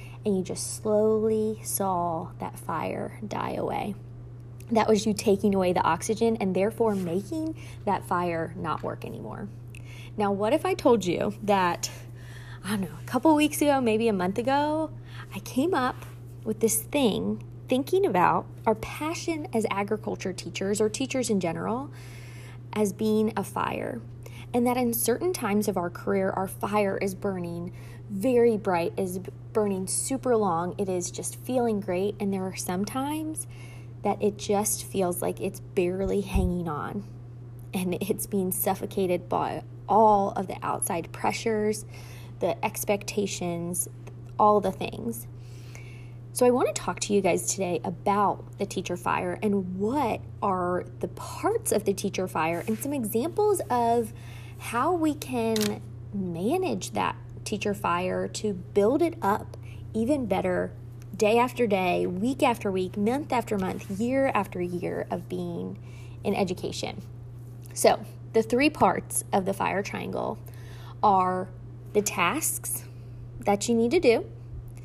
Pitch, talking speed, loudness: 185 Hz, 150 wpm, -27 LUFS